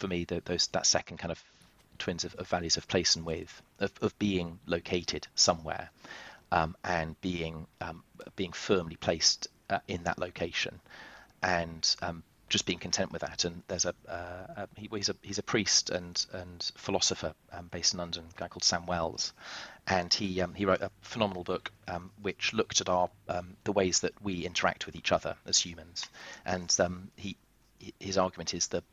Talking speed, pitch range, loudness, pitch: 195 wpm, 85-95 Hz, -31 LUFS, 90 Hz